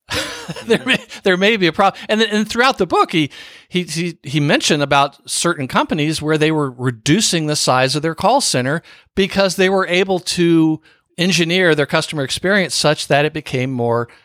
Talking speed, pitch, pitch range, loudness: 180 wpm, 165 Hz, 150-190 Hz, -16 LUFS